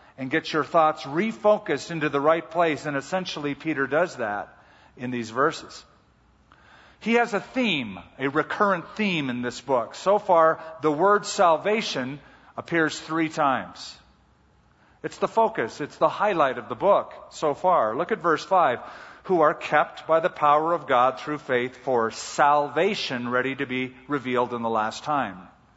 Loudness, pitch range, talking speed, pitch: -24 LUFS, 130-175 Hz, 165 wpm, 155 Hz